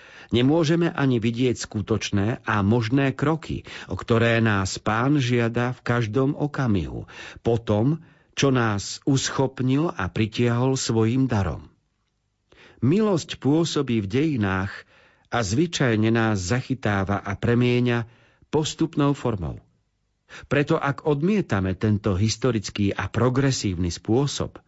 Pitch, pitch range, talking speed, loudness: 120 Hz, 105-140 Hz, 105 wpm, -23 LUFS